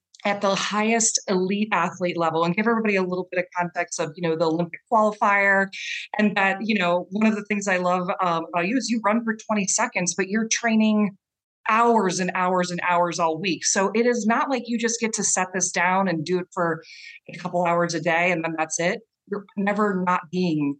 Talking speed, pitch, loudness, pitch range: 225 wpm, 190 Hz, -22 LUFS, 175-215 Hz